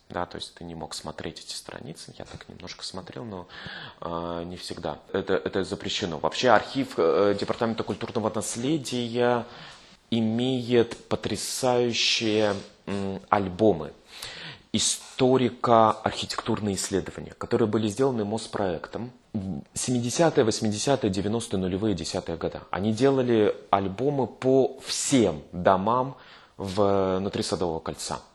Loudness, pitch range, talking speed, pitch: -26 LUFS, 95-120 Hz, 110 wpm, 110 Hz